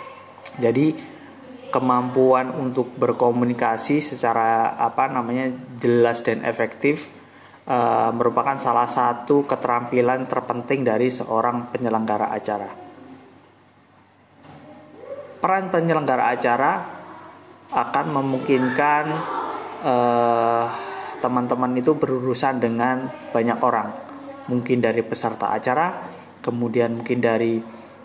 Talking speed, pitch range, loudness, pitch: 85 wpm, 120-135 Hz, -21 LUFS, 125 Hz